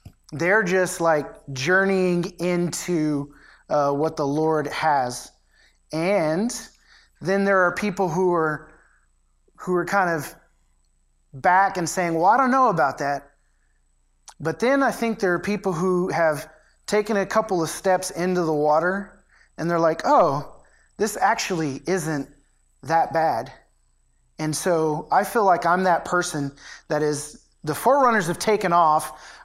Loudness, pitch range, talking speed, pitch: -22 LUFS, 150-190 Hz, 145 wpm, 170 Hz